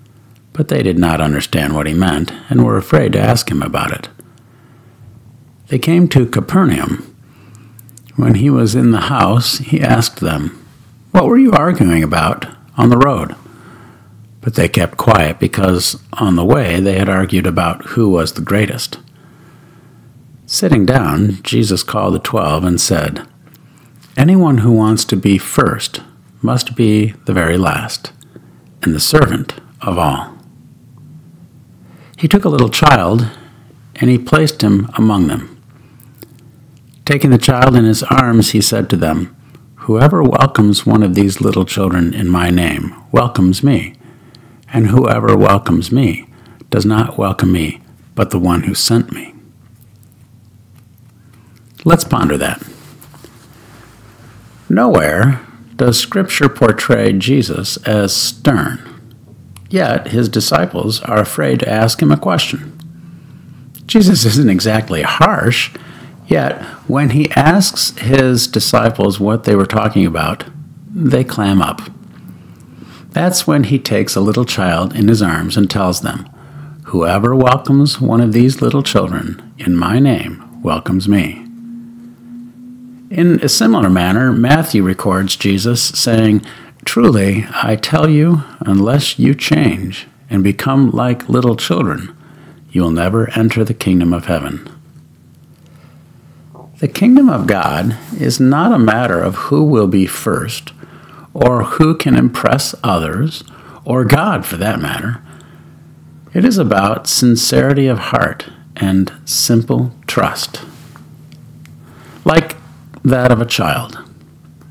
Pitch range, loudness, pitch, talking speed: 105-140 Hz, -13 LUFS, 120 Hz, 130 wpm